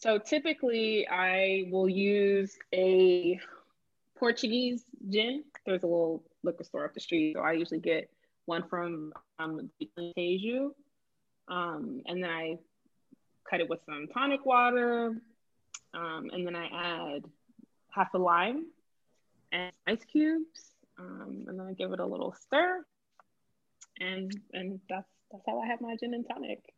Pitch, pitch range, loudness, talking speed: 200 Hz, 180-245 Hz, -31 LUFS, 145 wpm